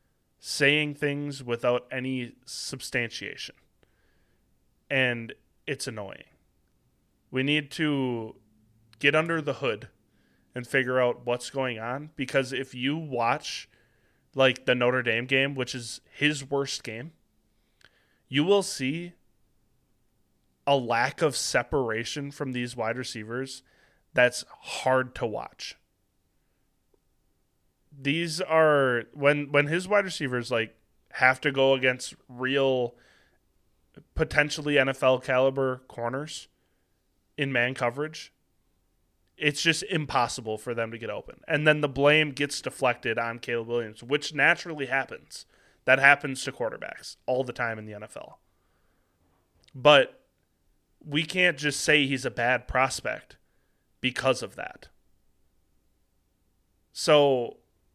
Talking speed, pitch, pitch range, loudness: 115 wpm, 130 Hz, 115-145 Hz, -26 LUFS